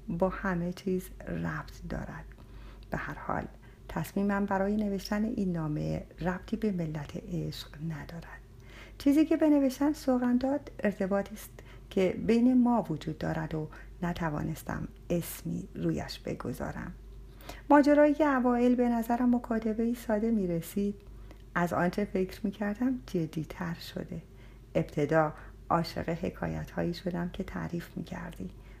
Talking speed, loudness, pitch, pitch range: 130 wpm, -31 LUFS, 185 Hz, 155-220 Hz